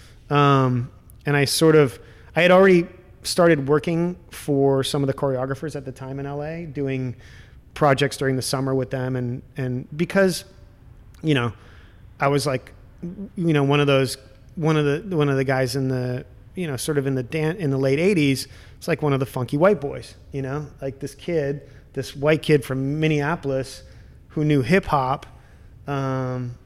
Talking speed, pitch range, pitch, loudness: 185 wpm, 130-150 Hz, 140 Hz, -22 LUFS